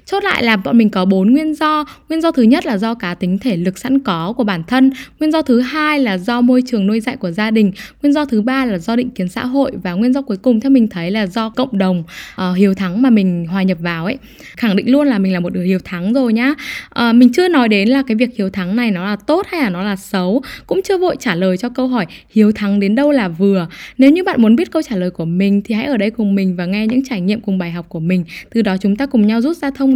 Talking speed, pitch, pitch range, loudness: 295 wpm, 225 Hz, 195-265 Hz, -15 LUFS